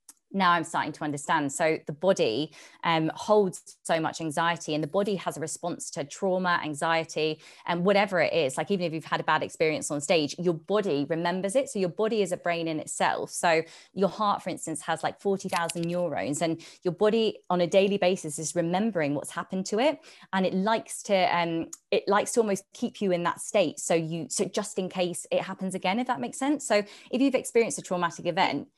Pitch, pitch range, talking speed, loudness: 180 Hz, 165-200 Hz, 220 wpm, -27 LUFS